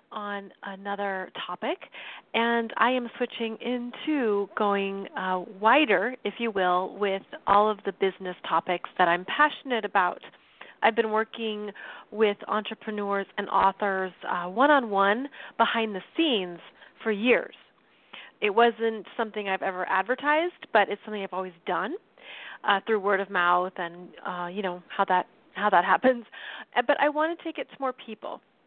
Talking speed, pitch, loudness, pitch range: 155 wpm, 210 Hz, -26 LUFS, 195-235 Hz